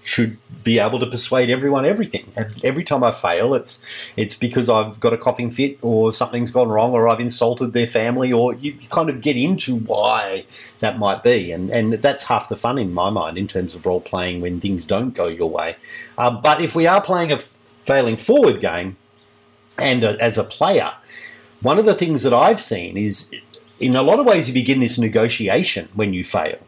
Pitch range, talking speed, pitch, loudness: 105-130 Hz, 210 wpm, 120 Hz, -18 LUFS